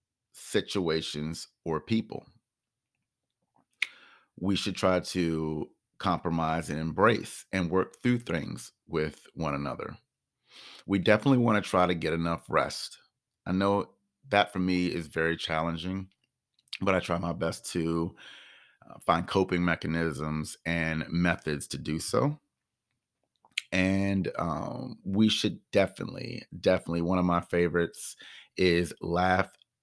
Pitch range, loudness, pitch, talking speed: 80-95 Hz, -29 LUFS, 90 Hz, 120 wpm